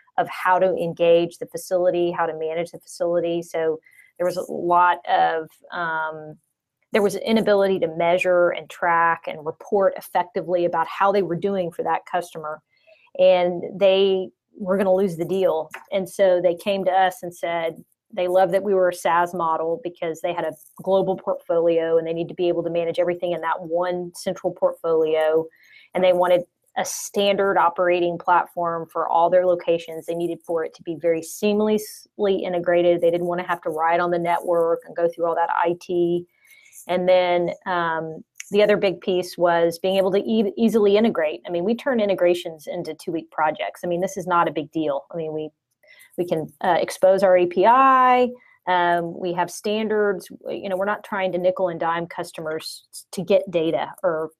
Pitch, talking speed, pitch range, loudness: 175 Hz, 190 wpm, 170-190 Hz, -21 LUFS